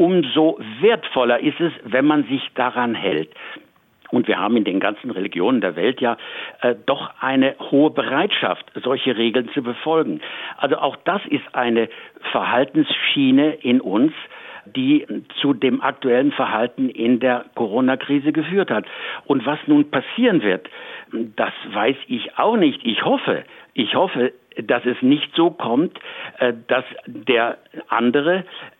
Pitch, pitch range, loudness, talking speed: 145 Hz, 130-175 Hz, -20 LUFS, 145 wpm